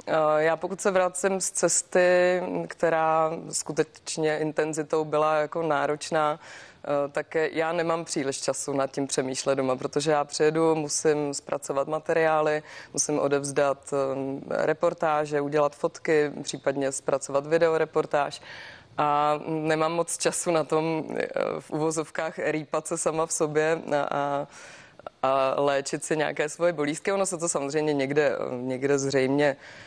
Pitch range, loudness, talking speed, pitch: 140-160 Hz, -26 LUFS, 125 wpm, 155 Hz